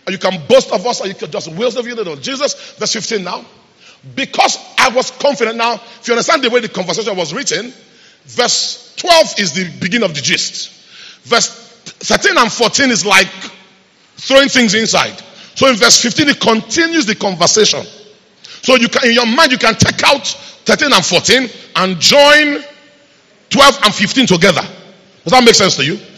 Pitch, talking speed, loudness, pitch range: 230 Hz, 185 wpm, -11 LUFS, 195-255 Hz